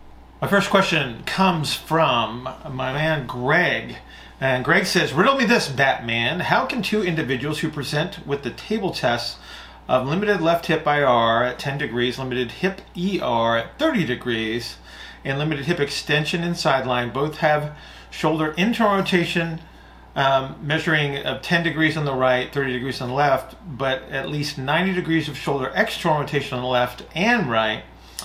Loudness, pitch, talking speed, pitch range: -21 LUFS, 150 Hz, 165 wpm, 130-170 Hz